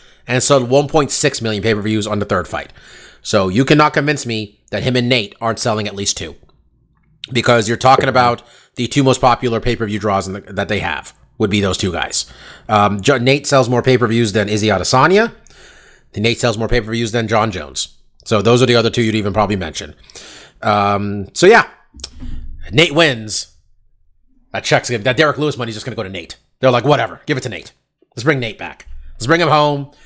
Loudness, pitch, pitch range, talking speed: -15 LUFS, 115 Hz, 100-130 Hz, 200 wpm